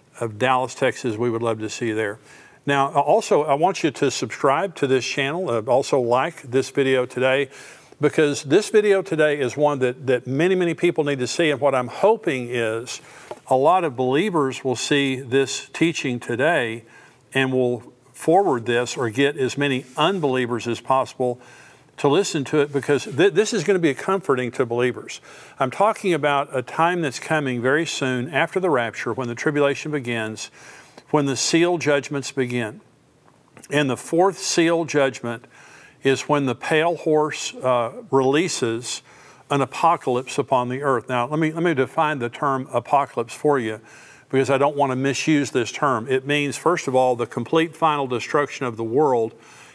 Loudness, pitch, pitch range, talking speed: -21 LUFS, 135 Hz, 125-150 Hz, 175 wpm